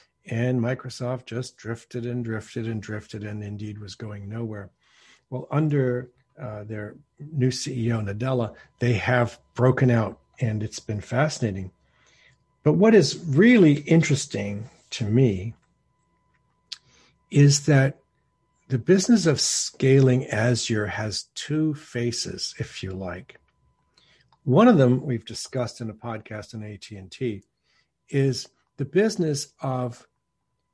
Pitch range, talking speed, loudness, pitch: 105-135 Hz, 120 wpm, -23 LUFS, 120 Hz